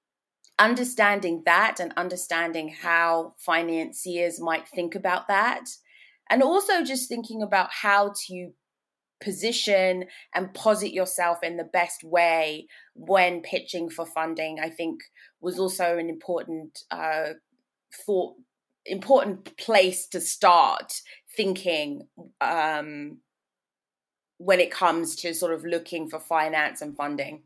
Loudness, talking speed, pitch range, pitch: -25 LUFS, 120 wpm, 165-200 Hz, 175 Hz